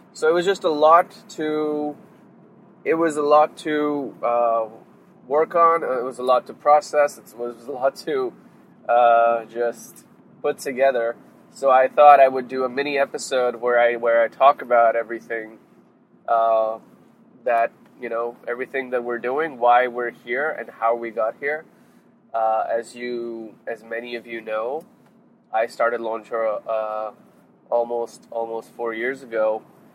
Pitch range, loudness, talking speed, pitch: 115-145 Hz, -21 LUFS, 160 wpm, 120 Hz